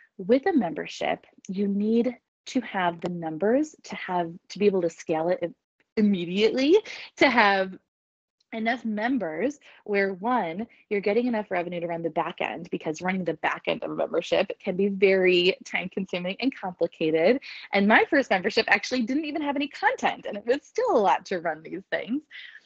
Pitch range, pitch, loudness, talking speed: 185-255 Hz, 210 Hz, -25 LUFS, 180 wpm